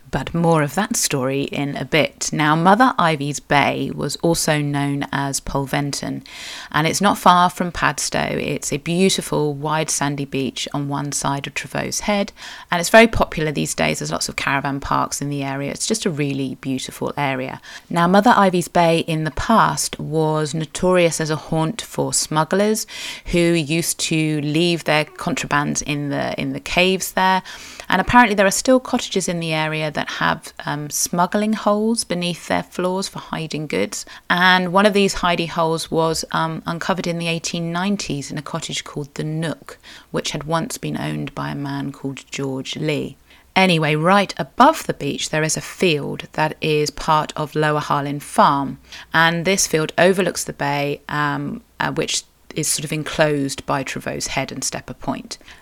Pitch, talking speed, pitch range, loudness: 155 Hz, 180 wpm, 140-180 Hz, -19 LUFS